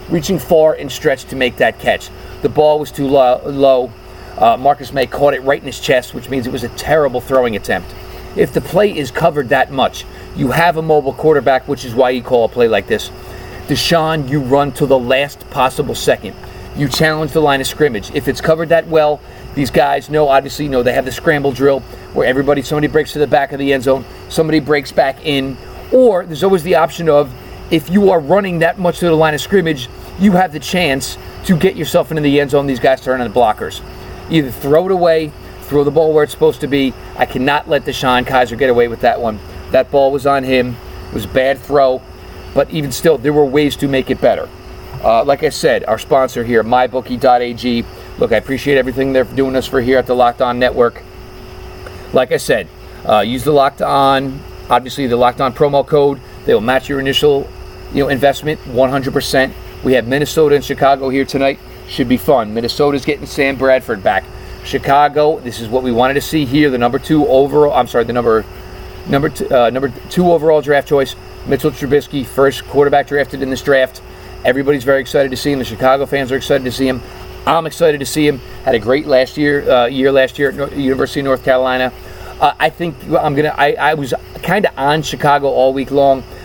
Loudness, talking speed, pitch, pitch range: -14 LUFS, 220 wpm, 135 Hz, 125-150 Hz